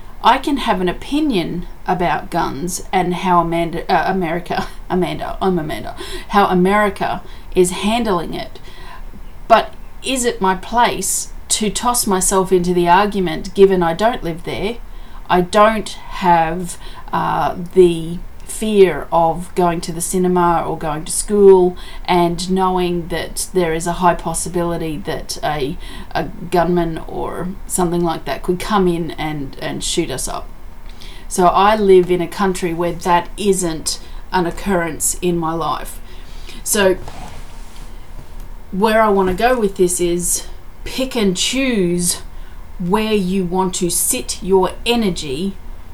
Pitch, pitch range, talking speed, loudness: 180 Hz, 170-195 Hz, 140 wpm, -17 LUFS